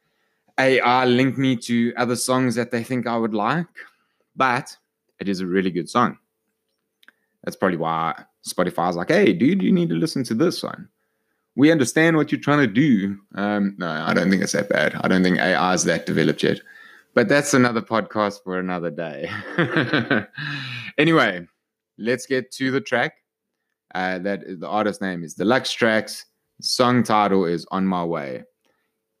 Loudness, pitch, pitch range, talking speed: -21 LUFS, 115 Hz, 95-130 Hz, 175 wpm